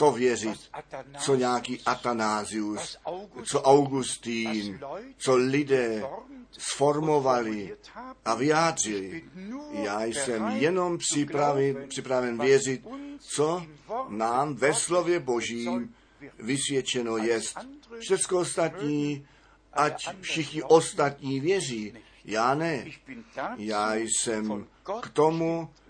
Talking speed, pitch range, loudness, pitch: 85 wpm, 120-165 Hz, -27 LUFS, 140 Hz